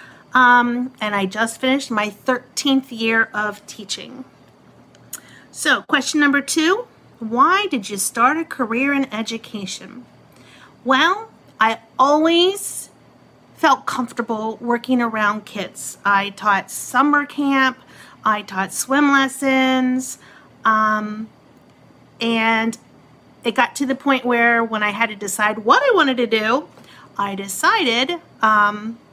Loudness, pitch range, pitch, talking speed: -18 LUFS, 215-270 Hz, 240 Hz, 120 wpm